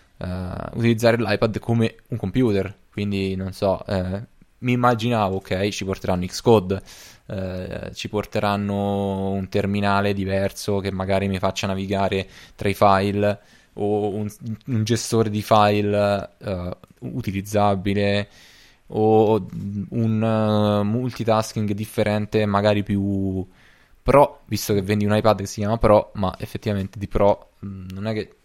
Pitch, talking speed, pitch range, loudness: 105 Hz, 135 wpm, 95-110 Hz, -22 LUFS